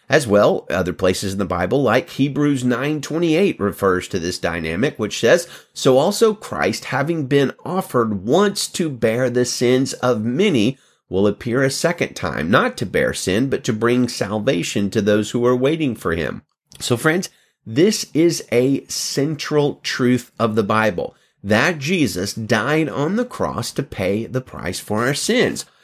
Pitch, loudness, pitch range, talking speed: 130 Hz, -19 LUFS, 115-150 Hz, 165 wpm